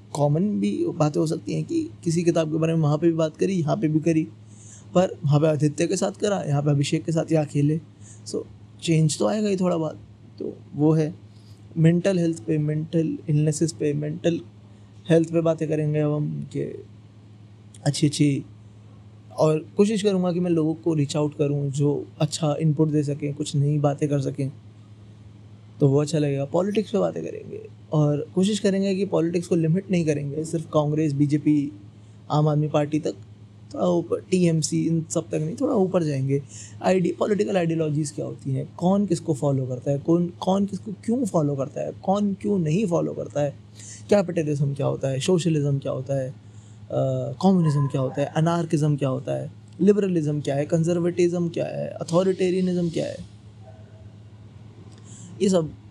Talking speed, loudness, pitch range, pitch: 180 wpm, -24 LUFS, 130-170 Hz, 150 Hz